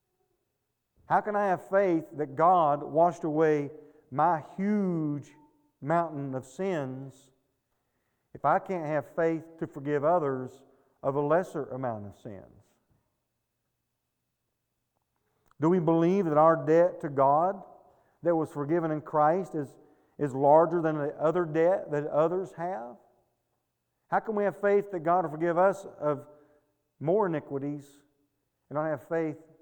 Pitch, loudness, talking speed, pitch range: 155 Hz, -28 LUFS, 140 wpm, 145-175 Hz